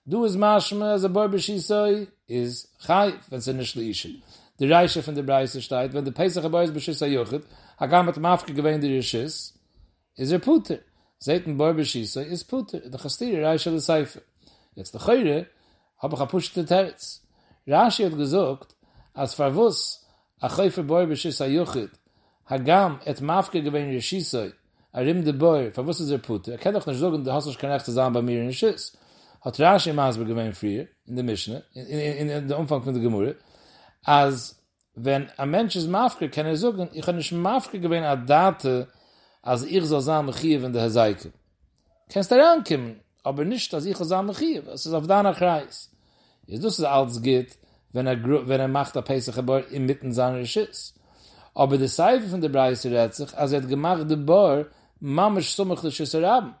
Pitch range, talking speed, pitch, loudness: 130-180 Hz, 190 wpm, 145 Hz, -24 LUFS